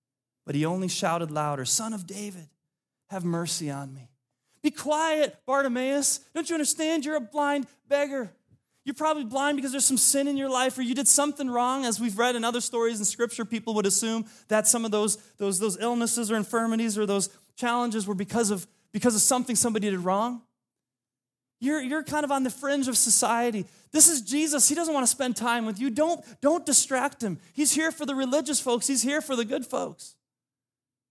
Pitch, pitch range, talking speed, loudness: 235 Hz, 200-275 Hz, 205 wpm, -25 LUFS